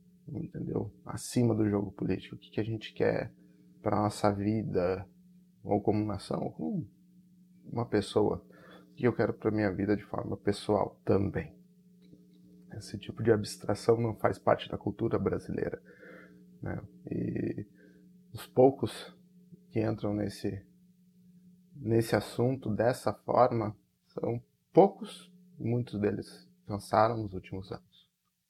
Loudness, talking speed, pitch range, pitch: -32 LUFS, 125 wpm, 100-150 Hz, 110 Hz